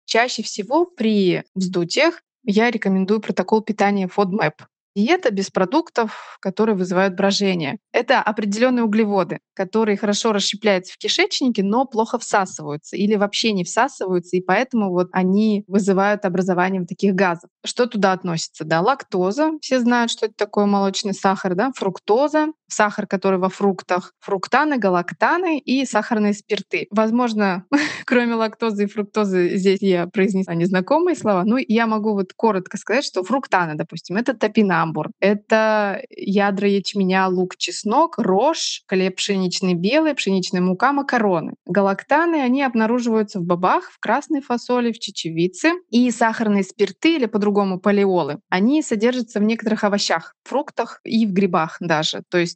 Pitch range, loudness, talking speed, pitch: 190-235 Hz, -20 LUFS, 140 wpm, 205 Hz